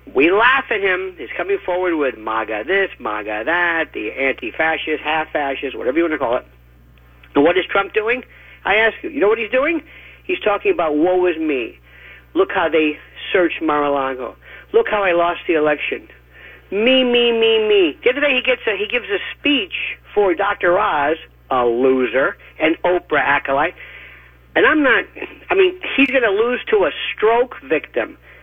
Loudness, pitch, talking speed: -17 LUFS, 195 Hz, 180 wpm